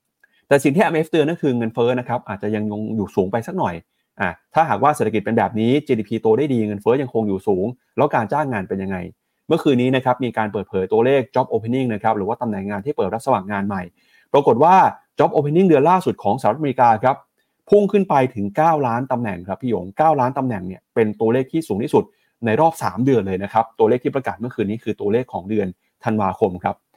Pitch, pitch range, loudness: 115 Hz, 105-140 Hz, -19 LUFS